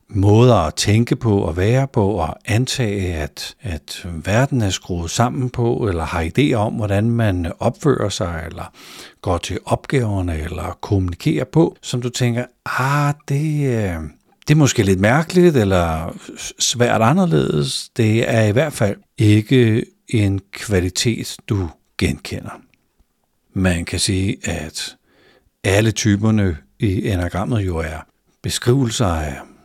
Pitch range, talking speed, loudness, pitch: 90-125 Hz, 135 wpm, -18 LUFS, 105 Hz